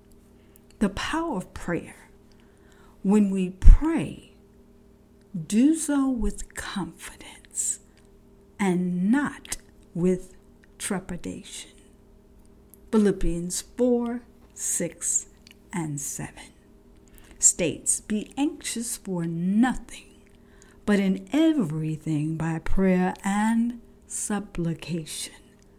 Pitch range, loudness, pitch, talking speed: 180-235 Hz, -26 LUFS, 200 Hz, 75 wpm